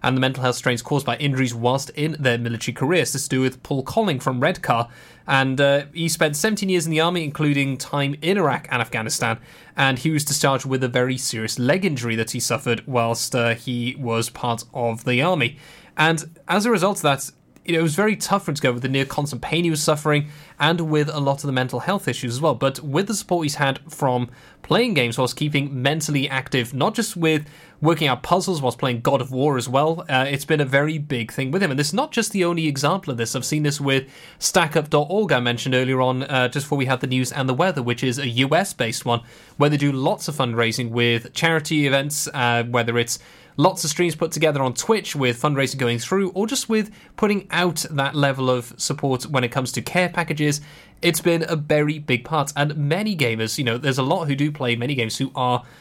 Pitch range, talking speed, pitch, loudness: 125-160 Hz, 235 wpm, 140 Hz, -21 LUFS